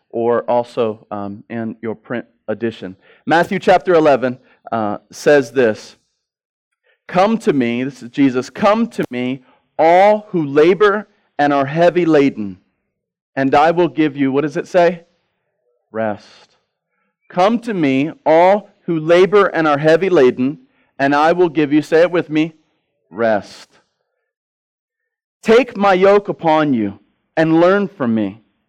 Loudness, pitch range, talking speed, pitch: -15 LUFS, 135-190 Hz, 140 wpm, 160 Hz